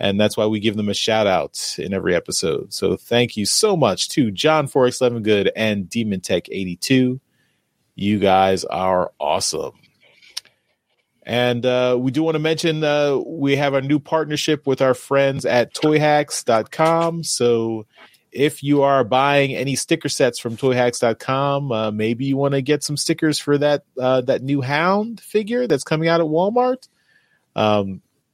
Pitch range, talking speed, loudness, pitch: 115-150 Hz, 165 wpm, -19 LUFS, 135 Hz